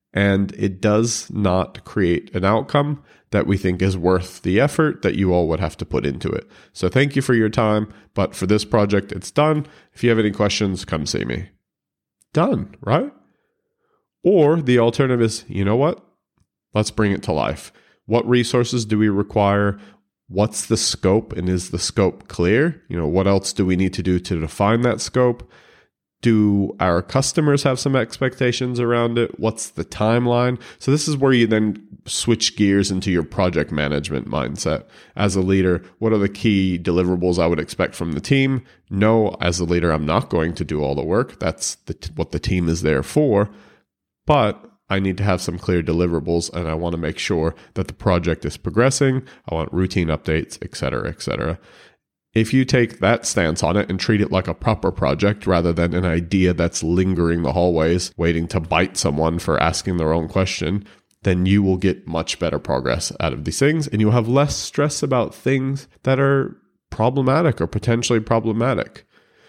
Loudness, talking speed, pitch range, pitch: -20 LUFS, 195 wpm, 90-120 Hz, 100 Hz